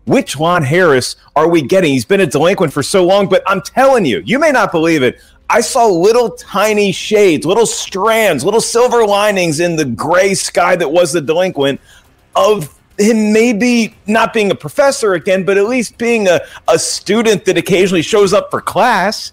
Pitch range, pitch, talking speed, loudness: 175-225 Hz, 195 Hz, 190 wpm, -12 LUFS